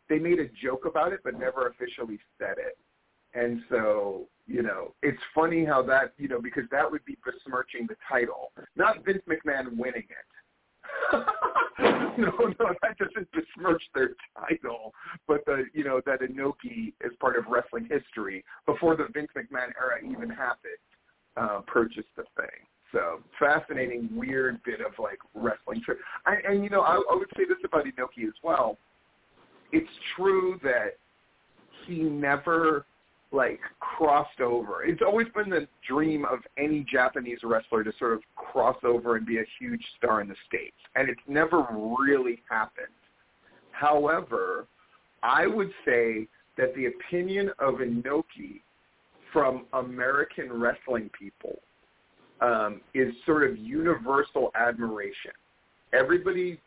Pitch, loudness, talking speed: 165 Hz, -28 LUFS, 145 wpm